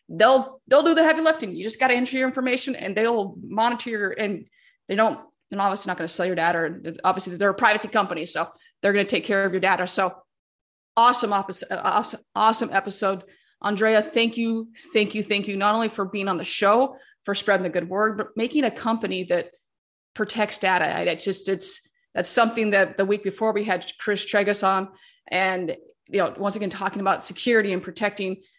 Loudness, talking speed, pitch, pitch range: -23 LUFS, 205 wpm, 205 Hz, 190-230 Hz